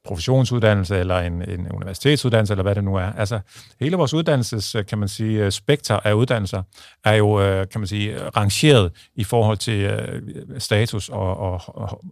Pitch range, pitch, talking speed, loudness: 100-115 Hz, 105 Hz, 160 wpm, -20 LUFS